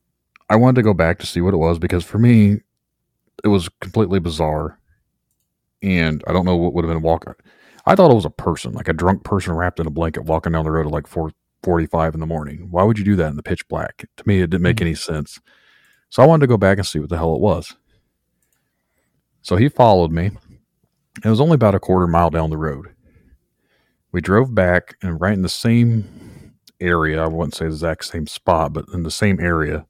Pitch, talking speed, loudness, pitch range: 90 Hz, 235 wpm, -18 LUFS, 80-100 Hz